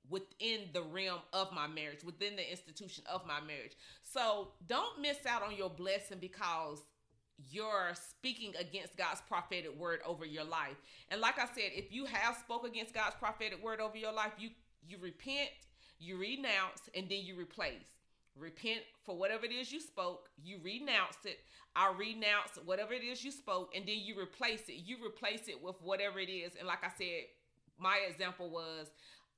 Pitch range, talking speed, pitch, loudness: 175-225 Hz, 180 wpm, 195 Hz, -40 LUFS